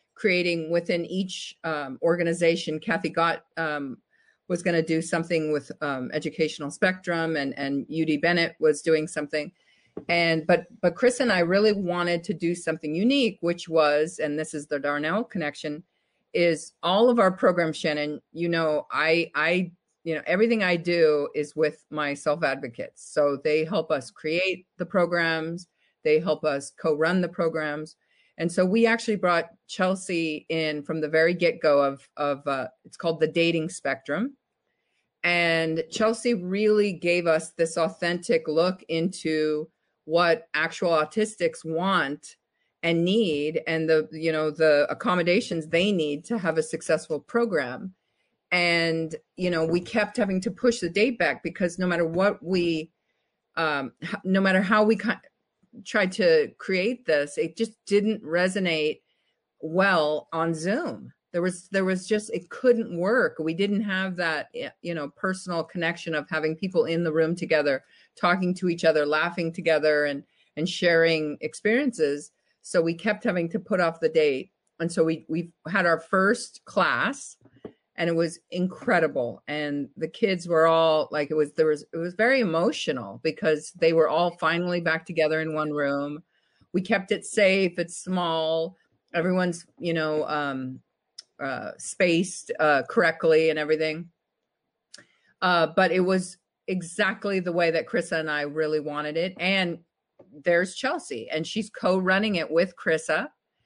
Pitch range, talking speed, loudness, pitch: 155-185 Hz, 160 wpm, -25 LUFS, 170 Hz